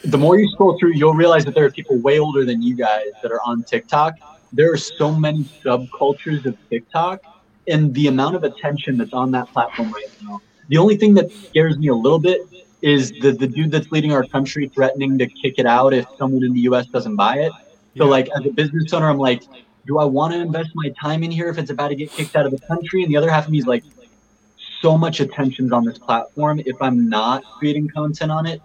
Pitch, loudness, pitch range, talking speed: 150 Hz, -18 LUFS, 130-160 Hz, 240 wpm